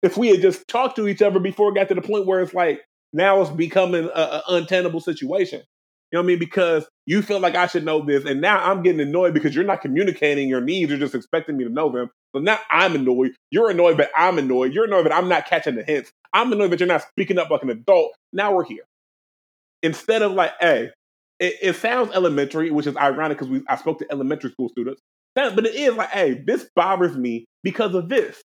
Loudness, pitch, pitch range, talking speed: -20 LUFS, 180 Hz, 150-205 Hz, 240 wpm